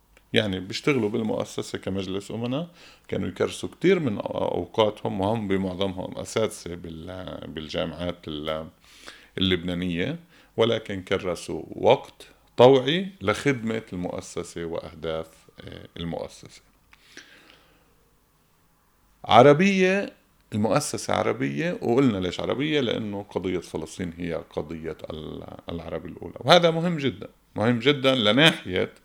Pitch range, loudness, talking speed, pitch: 85-130 Hz, -24 LUFS, 85 wpm, 100 Hz